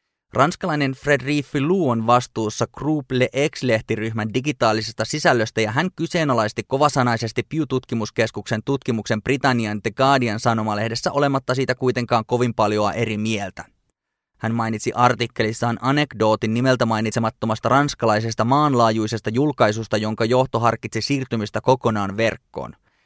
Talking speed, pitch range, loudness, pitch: 110 wpm, 110-135 Hz, -21 LUFS, 120 Hz